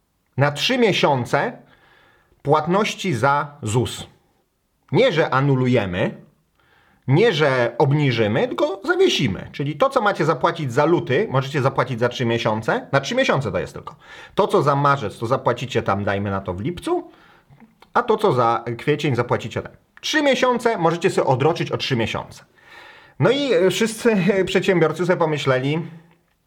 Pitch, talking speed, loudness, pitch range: 150 Hz, 145 wpm, -20 LUFS, 125-195 Hz